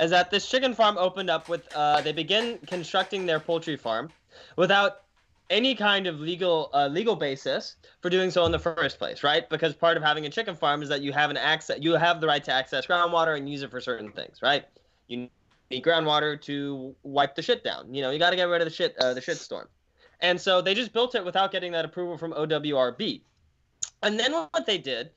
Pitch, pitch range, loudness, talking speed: 165 Hz, 150-185 Hz, -26 LUFS, 230 wpm